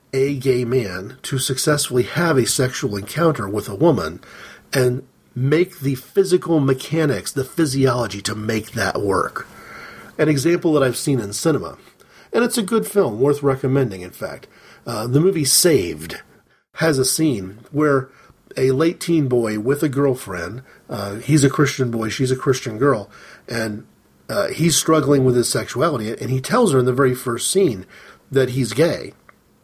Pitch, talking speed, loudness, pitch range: 135 Hz, 165 wpm, -19 LUFS, 120-155 Hz